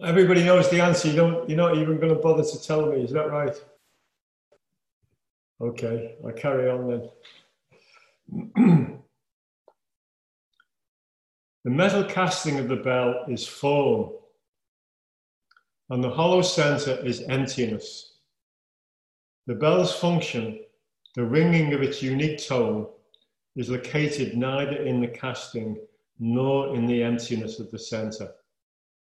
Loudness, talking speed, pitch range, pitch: -24 LUFS, 120 wpm, 120-170 Hz, 140 Hz